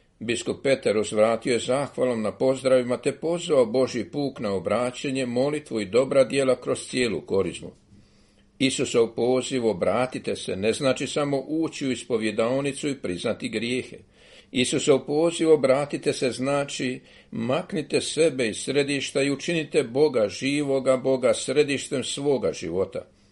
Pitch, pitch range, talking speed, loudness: 135 Hz, 125-145 Hz, 130 wpm, -24 LUFS